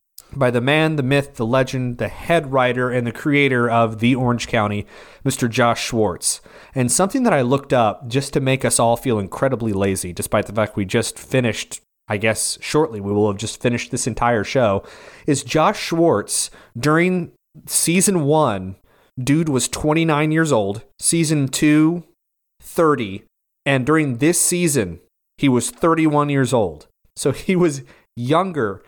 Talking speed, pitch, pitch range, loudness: 160 wpm, 130 Hz, 115-155 Hz, -19 LUFS